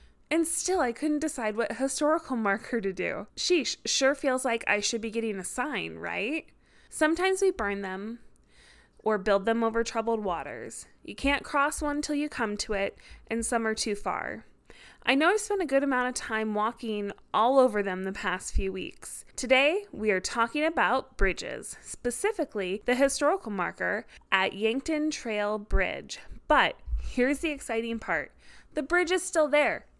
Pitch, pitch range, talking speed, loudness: 240 Hz, 215-300 Hz, 170 wpm, -28 LUFS